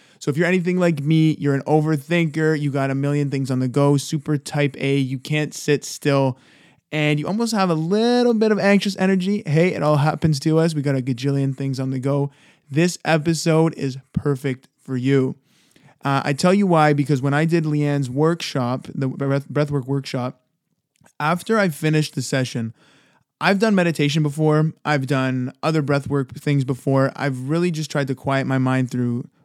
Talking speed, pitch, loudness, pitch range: 185 wpm, 145 Hz, -20 LUFS, 135-160 Hz